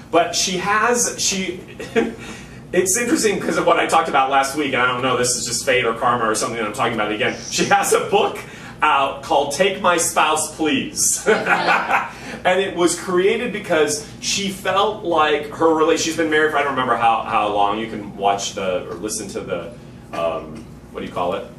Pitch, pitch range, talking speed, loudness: 160 Hz, 125-190 Hz, 210 wpm, -18 LUFS